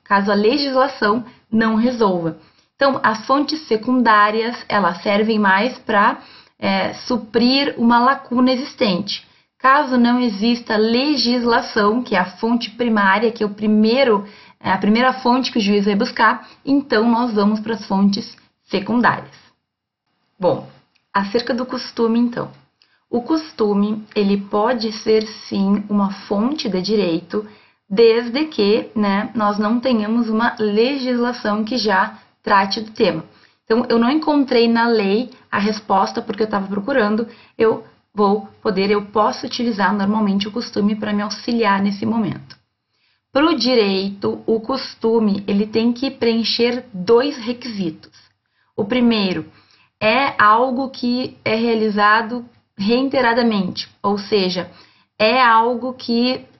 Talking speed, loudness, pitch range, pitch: 135 wpm, -18 LUFS, 210-245 Hz, 225 Hz